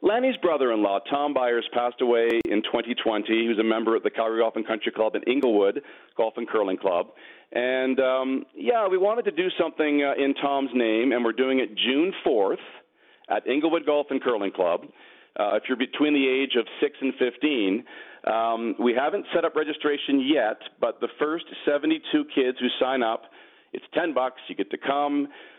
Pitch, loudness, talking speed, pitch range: 135 Hz, -25 LUFS, 195 wpm, 120-165 Hz